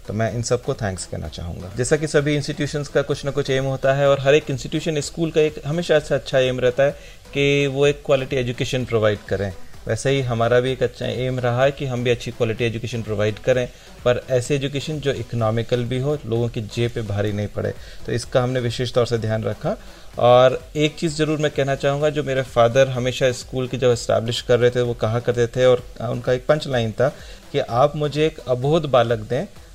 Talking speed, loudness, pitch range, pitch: 225 wpm, -21 LUFS, 120-140 Hz, 125 Hz